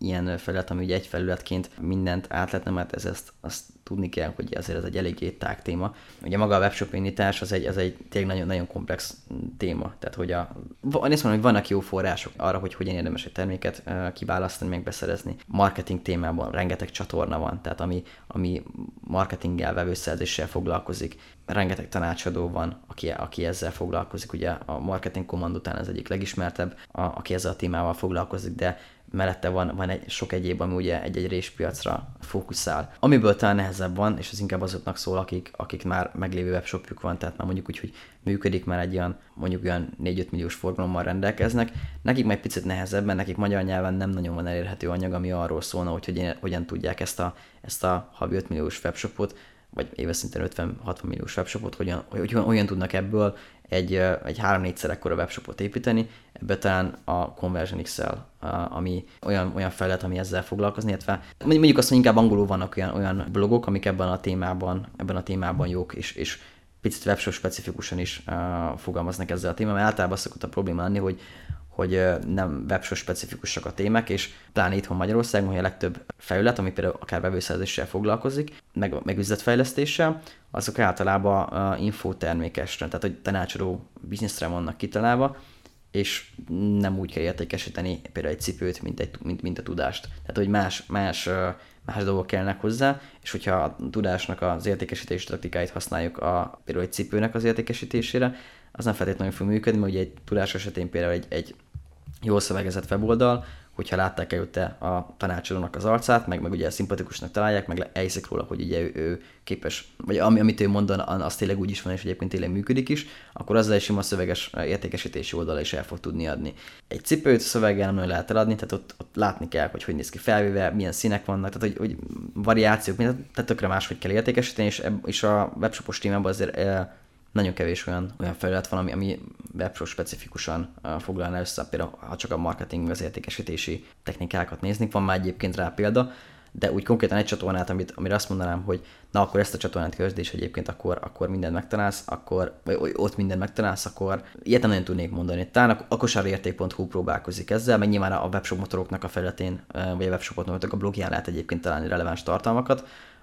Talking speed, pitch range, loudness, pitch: 180 wpm, 90-100 Hz, -27 LUFS, 95 Hz